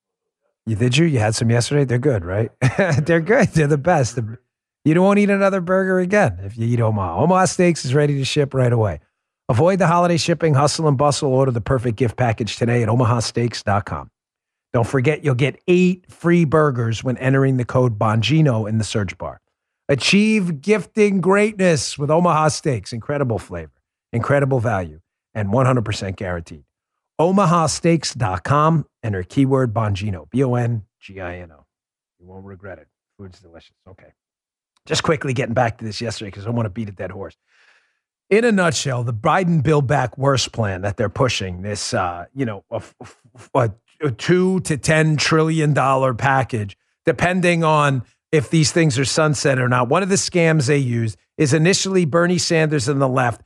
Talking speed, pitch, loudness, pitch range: 175 wpm, 135 Hz, -18 LUFS, 115-160 Hz